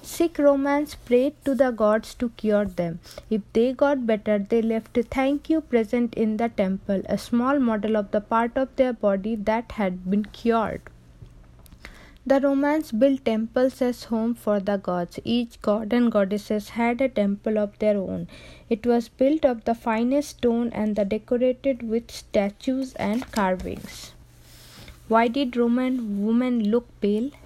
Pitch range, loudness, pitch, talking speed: 210-255 Hz, -24 LUFS, 230 Hz, 160 wpm